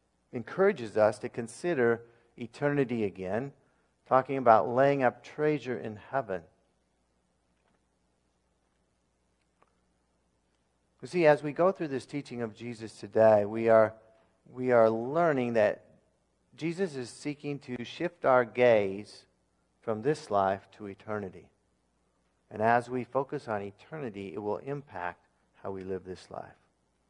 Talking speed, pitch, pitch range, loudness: 125 wpm, 110 Hz, 90-130 Hz, -29 LUFS